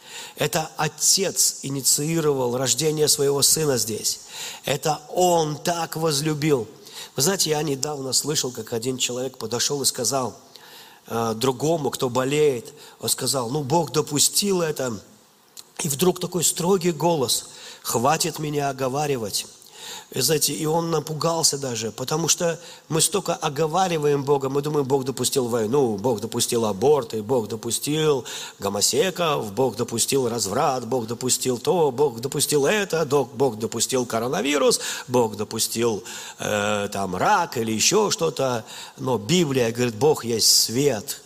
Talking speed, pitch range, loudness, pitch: 130 wpm, 125-160 Hz, -22 LUFS, 145 Hz